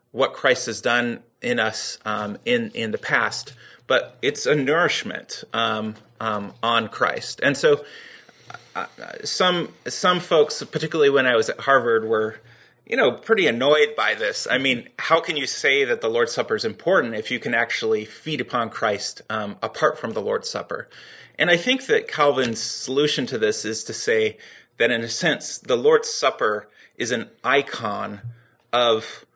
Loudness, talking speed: -22 LUFS, 175 wpm